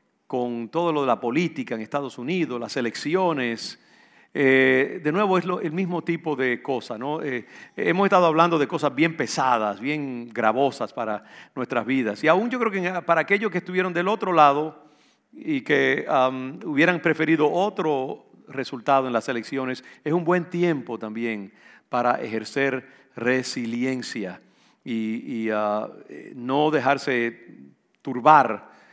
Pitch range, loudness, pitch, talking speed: 125-170 Hz, -23 LUFS, 140 Hz, 145 wpm